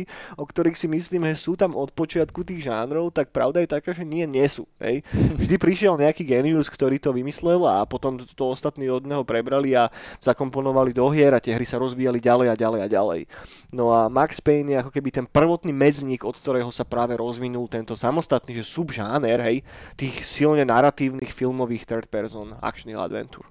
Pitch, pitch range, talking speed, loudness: 135 Hz, 120-155 Hz, 190 wpm, -23 LUFS